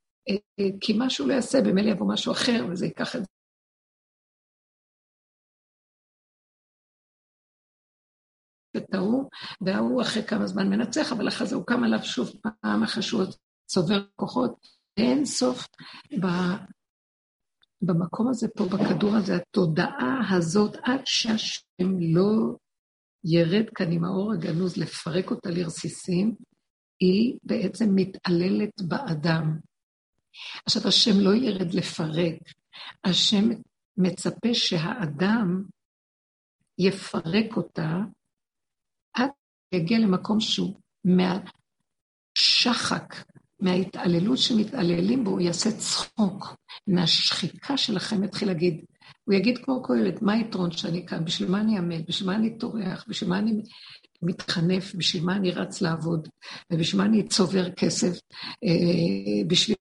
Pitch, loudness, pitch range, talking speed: 195 Hz, -25 LUFS, 180-220 Hz, 110 wpm